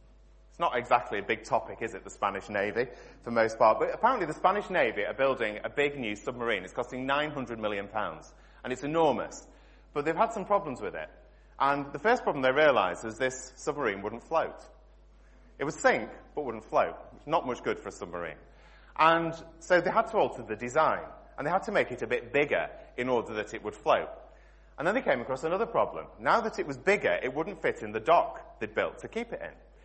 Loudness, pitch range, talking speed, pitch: -30 LUFS, 125-195 Hz, 220 wpm, 145 Hz